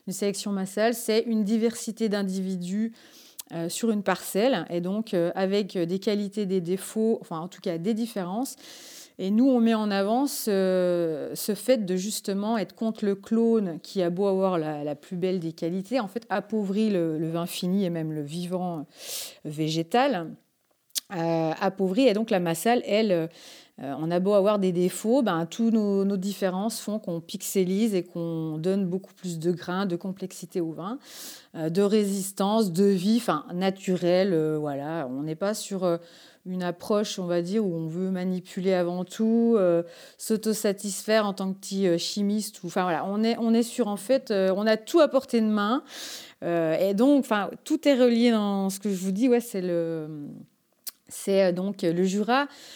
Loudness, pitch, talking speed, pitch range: -26 LUFS, 195 Hz, 190 wpm, 180-220 Hz